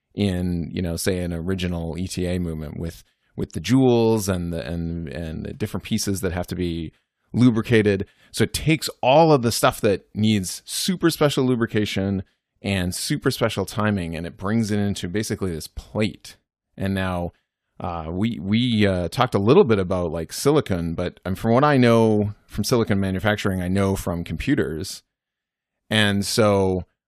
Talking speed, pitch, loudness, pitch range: 165 wpm, 100 Hz, -22 LUFS, 90-110 Hz